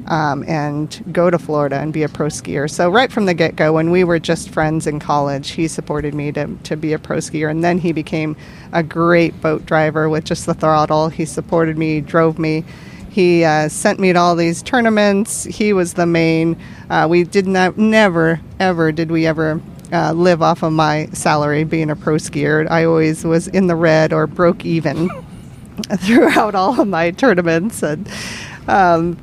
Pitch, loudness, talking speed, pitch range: 165 Hz, -16 LUFS, 195 wpm, 155-175 Hz